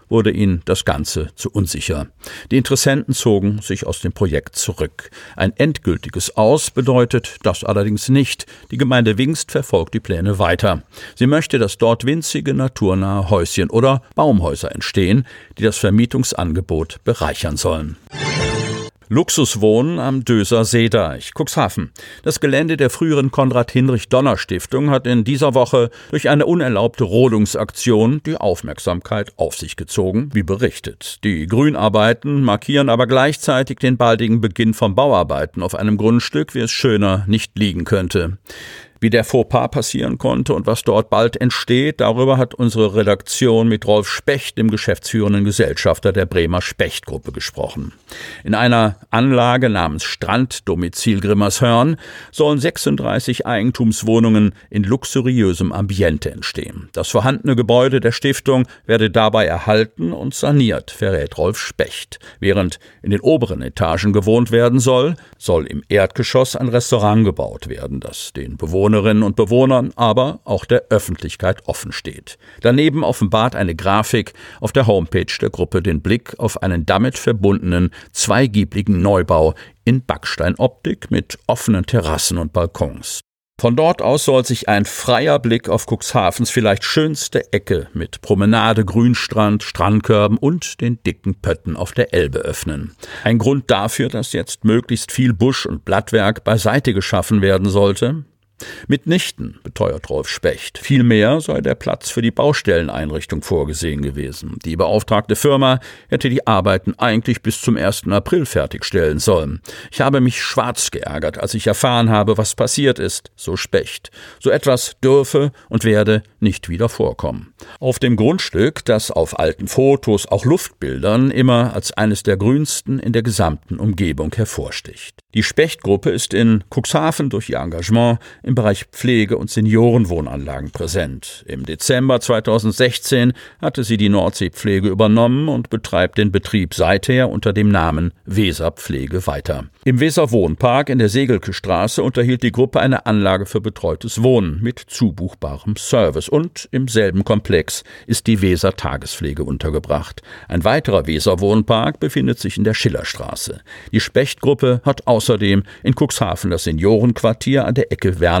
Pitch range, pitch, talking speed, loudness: 100-125 Hz, 110 Hz, 140 wpm, -16 LUFS